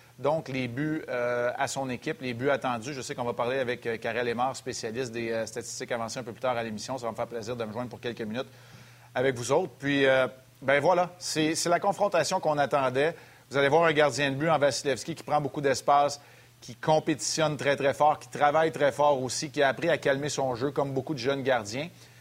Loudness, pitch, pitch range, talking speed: -28 LUFS, 135 Hz, 125-150 Hz, 240 wpm